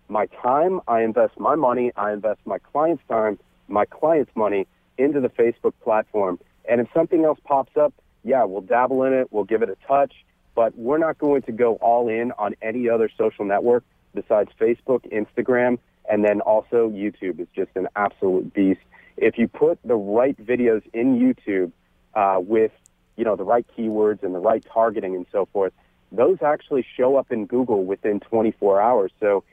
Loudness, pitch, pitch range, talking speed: -21 LUFS, 115 Hz, 105-125 Hz, 185 wpm